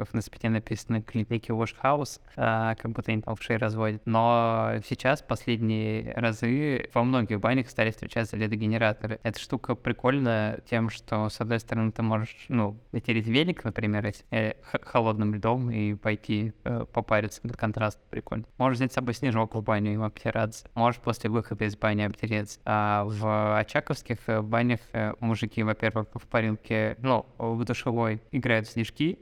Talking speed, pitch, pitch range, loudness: 155 wpm, 115 Hz, 110-120 Hz, -28 LUFS